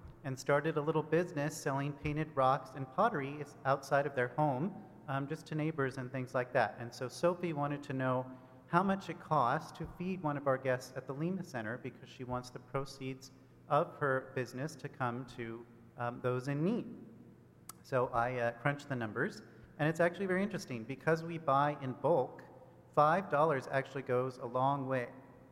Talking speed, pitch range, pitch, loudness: 185 wpm, 130-155 Hz, 135 Hz, -36 LUFS